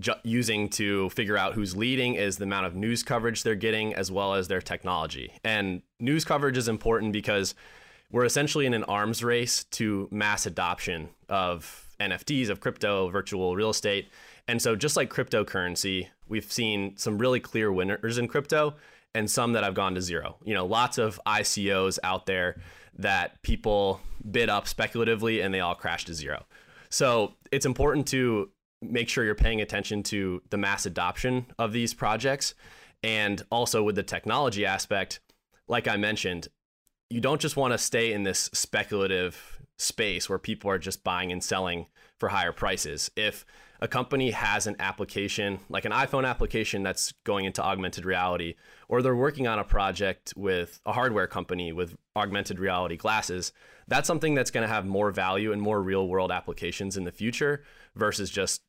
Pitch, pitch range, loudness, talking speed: 105 Hz, 95-115 Hz, -28 LUFS, 175 wpm